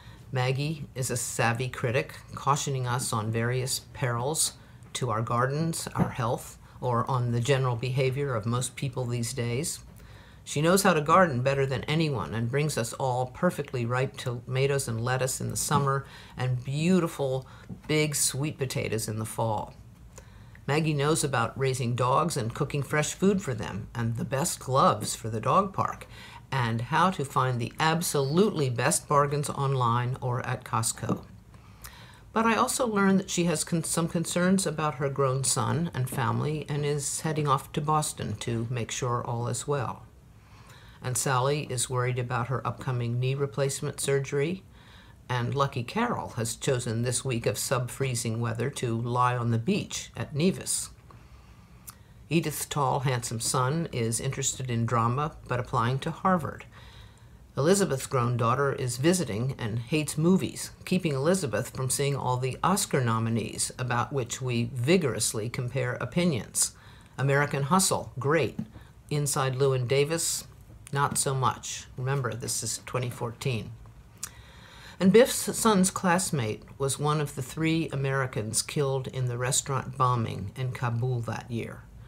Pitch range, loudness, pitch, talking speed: 120-145 Hz, -28 LUFS, 130 Hz, 150 wpm